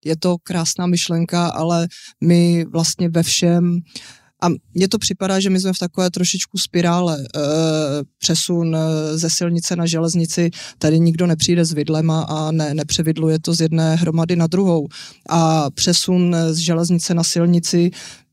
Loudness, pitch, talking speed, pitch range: -17 LUFS, 170 Hz, 150 wpm, 160-175 Hz